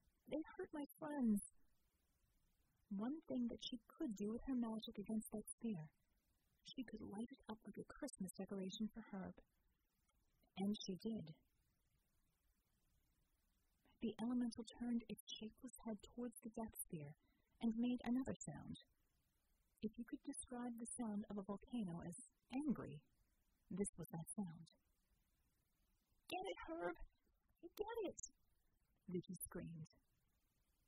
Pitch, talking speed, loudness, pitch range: 220 Hz, 130 wpm, -49 LUFS, 195-245 Hz